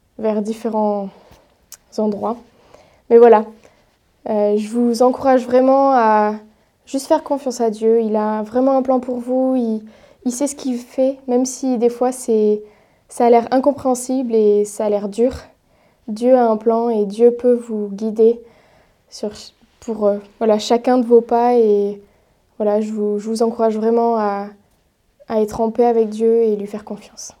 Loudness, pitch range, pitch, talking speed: -17 LUFS, 215-250 Hz, 230 Hz, 175 wpm